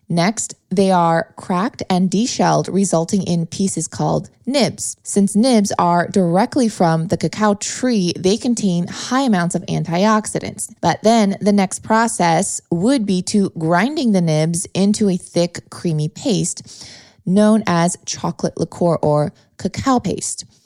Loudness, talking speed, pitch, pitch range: -17 LUFS, 140 wpm, 185 Hz, 170-210 Hz